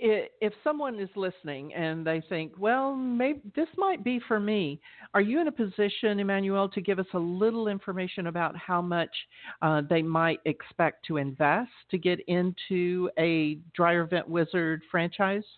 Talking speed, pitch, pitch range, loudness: 165 wpm, 185 Hz, 165-215 Hz, -29 LUFS